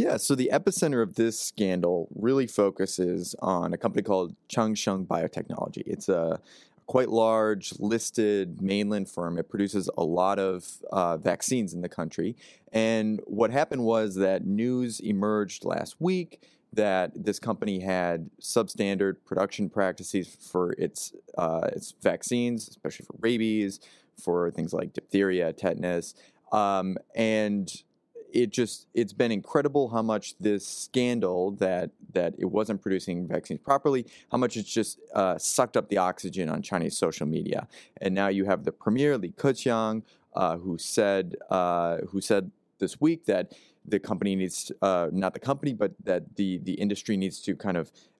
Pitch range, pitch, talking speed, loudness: 95-115 Hz, 105 Hz, 155 wpm, -28 LUFS